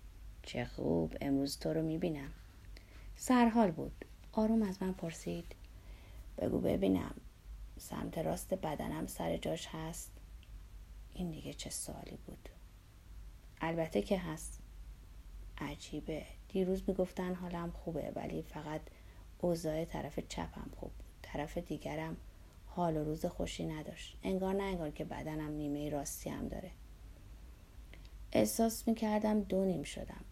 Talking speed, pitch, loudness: 120 wpm, 145 Hz, -38 LUFS